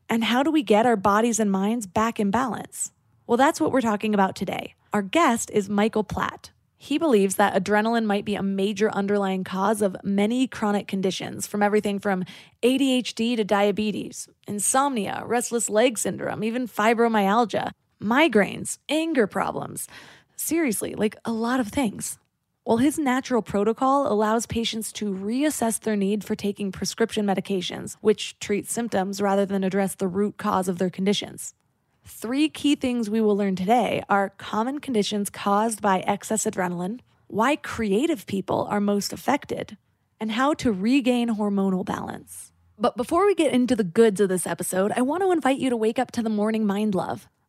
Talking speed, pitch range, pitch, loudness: 170 wpm, 200-240 Hz, 215 Hz, -24 LUFS